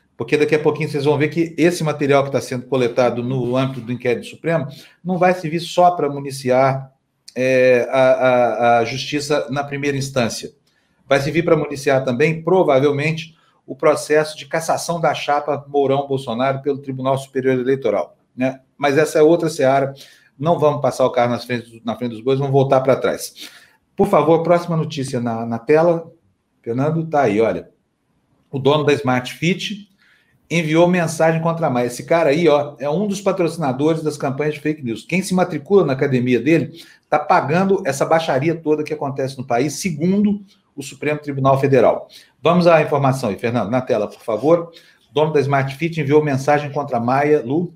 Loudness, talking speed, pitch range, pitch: -18 LUFS, 185 wpm, 130-160 Hz, 145 Hz